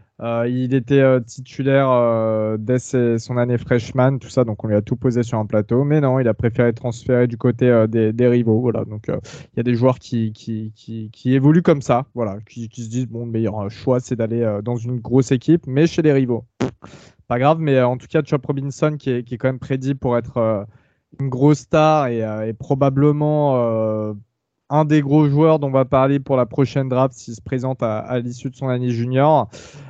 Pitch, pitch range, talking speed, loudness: 125 Hz, 115-135 Hz, 235 wpm, -19 LUFS